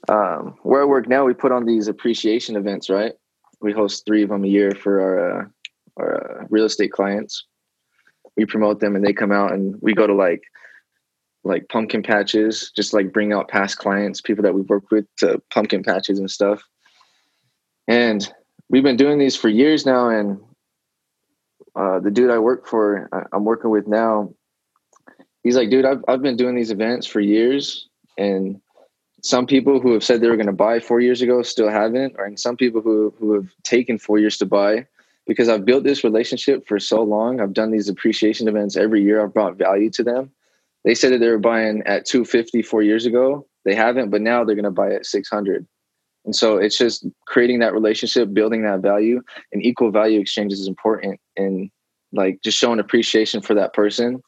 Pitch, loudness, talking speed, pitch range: 110 Hz, -18 LUFS, 200 wpm, 100-120 Hz